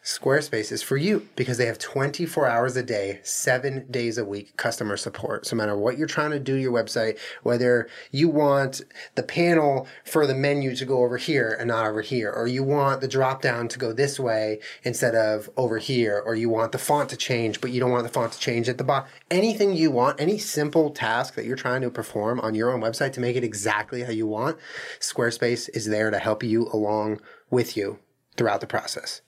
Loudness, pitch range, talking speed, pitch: -25 LUFS, 115-140 Hz, 225 wpm, 125 Hz